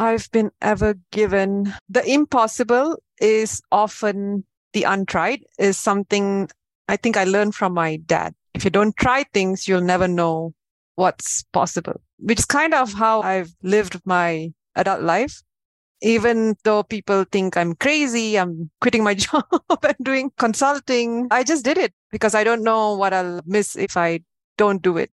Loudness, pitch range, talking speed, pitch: -20 LUFS, 190-235 Hz, 160 wpm, 210 Hz